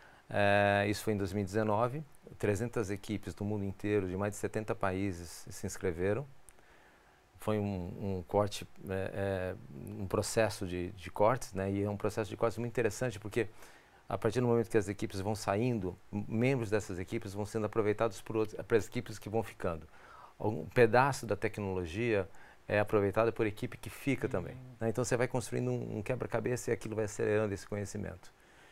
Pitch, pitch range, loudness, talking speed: 105 Hz, 100-115 Hz, -34 LUFS, 180 wpm